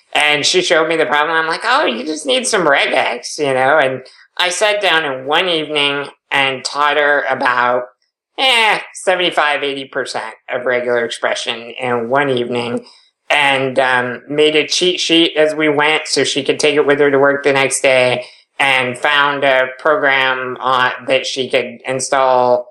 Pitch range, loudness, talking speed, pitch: 130-150 Hz, -14 LUFS, 175 wpm, 140 Hz